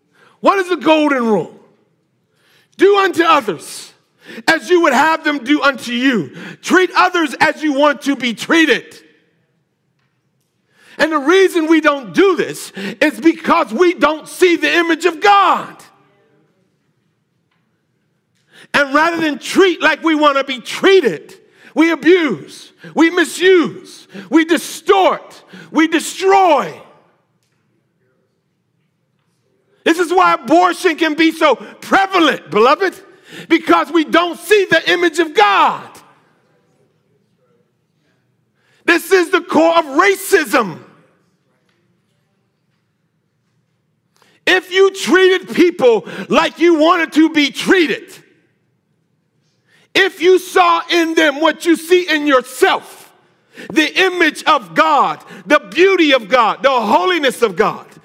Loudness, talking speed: -13 LUFS, 115 wpm